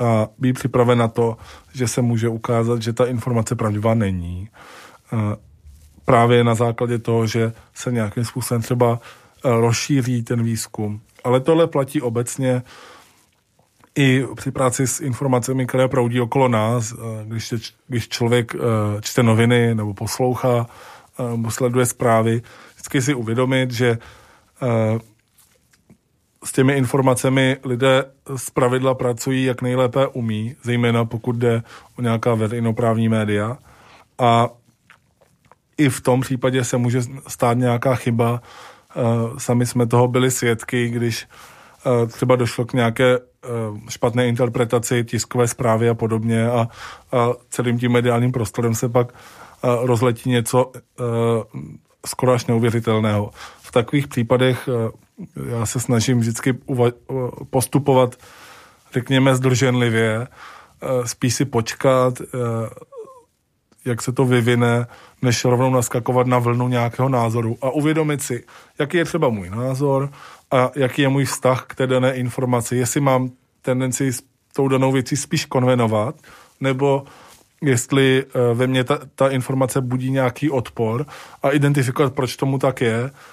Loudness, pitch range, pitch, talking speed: -20 LUFS, 115-130 Hz, 125 Hz, 130 wpm